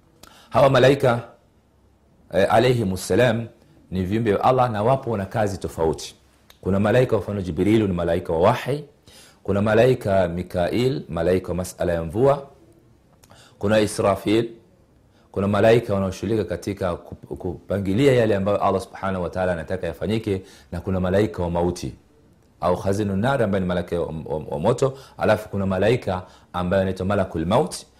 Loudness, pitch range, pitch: -22 LUFS, 90-115 Hz, 100 Hz